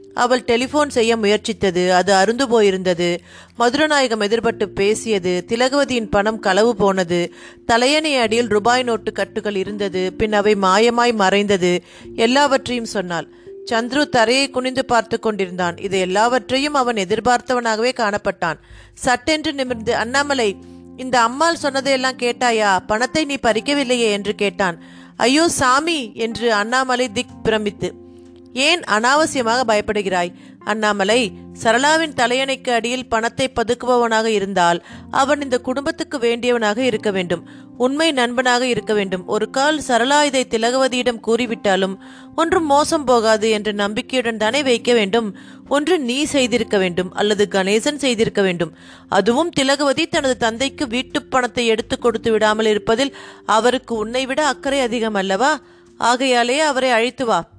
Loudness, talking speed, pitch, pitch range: -18 LUFS, 120 wpm, 235 Hz, 205-260 Hz